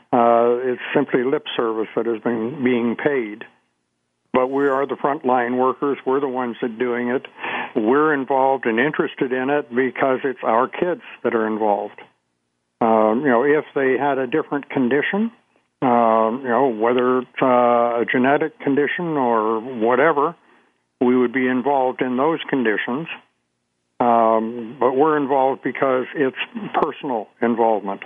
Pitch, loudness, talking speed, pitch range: 125 Hz, -20 LUFS, 155 wpm, 115-135 Hz